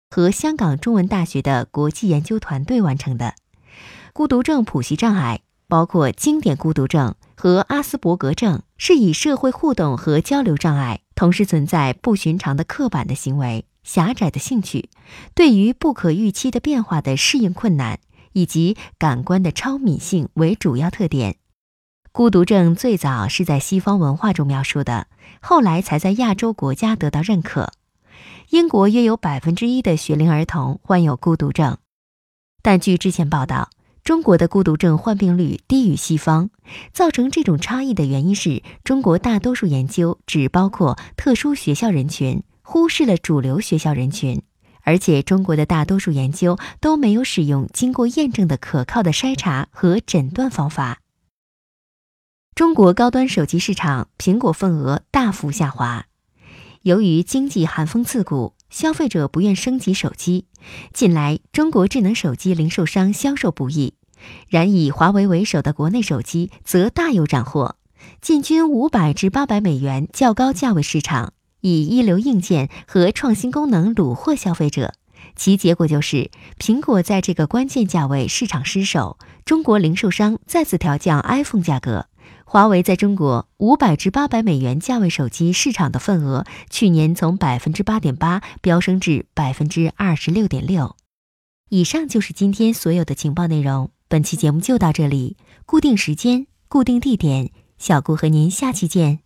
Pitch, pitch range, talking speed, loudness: 175 Hz, 150-220 Hz, 260 characters per minute, -18 LUFS